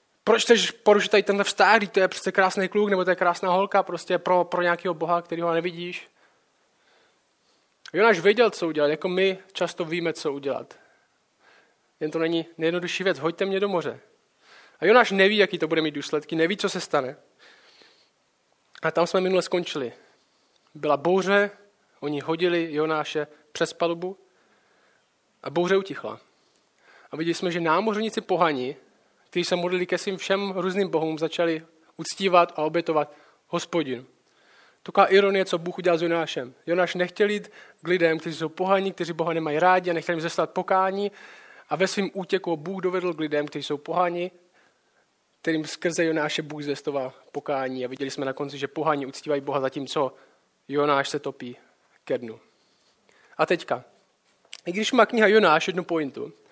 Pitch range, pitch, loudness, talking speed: 155-190 Hz, 175 Hz, -24 LUFS, 165 wpm